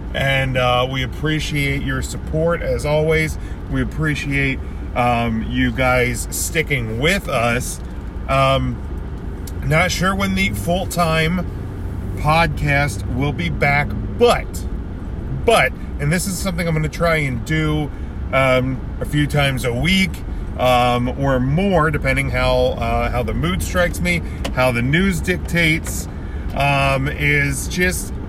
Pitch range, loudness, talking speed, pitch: 105-150 Hz, -18 LUFS, 130 wpm, 130 Hz